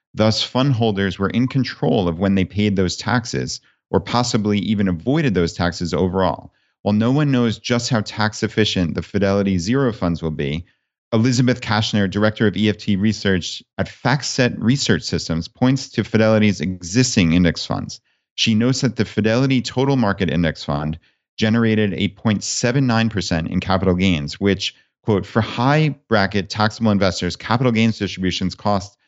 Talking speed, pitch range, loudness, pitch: 155 wpm, 95-120 Hz, -19 LUFS, 105 Hz